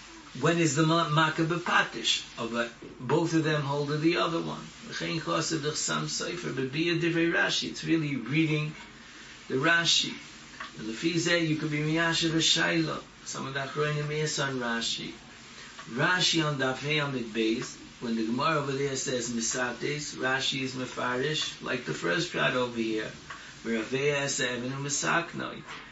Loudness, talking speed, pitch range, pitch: -28 LUFS, 185 wpm, 125-160 Hz, 145 Hz